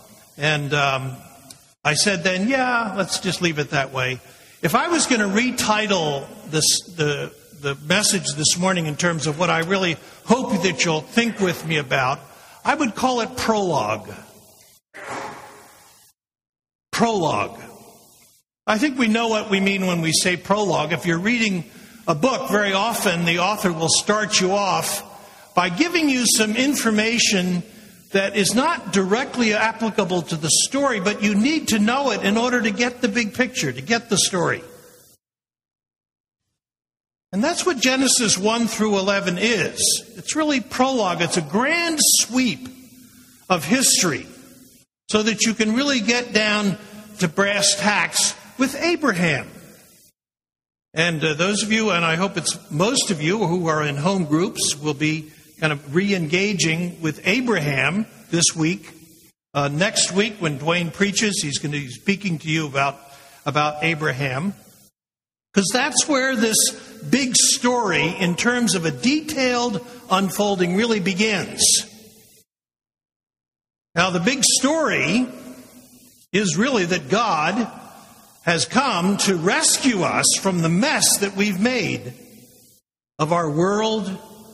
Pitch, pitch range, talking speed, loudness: 200 Hz, 170-230 Hz, 145 wpm, -20 LUFS